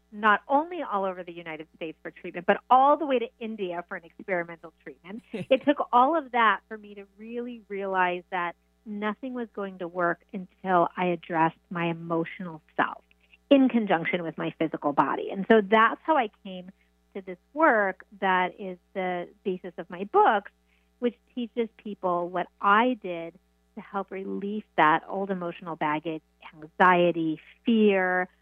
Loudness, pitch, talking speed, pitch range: -26 LUFS, 190 Hz, 165 wpm, 170-220 Hz